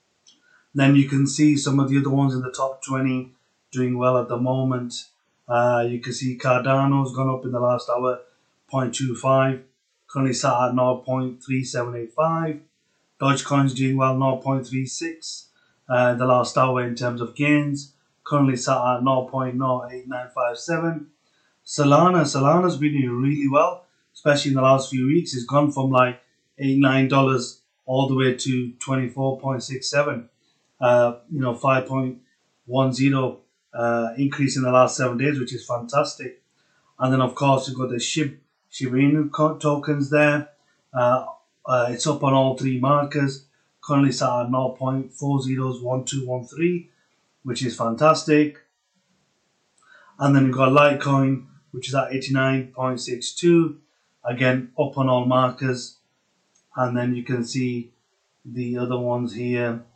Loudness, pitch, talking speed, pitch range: -22 LUFS, 130 Hz, 135 wpm, 125-140 Hz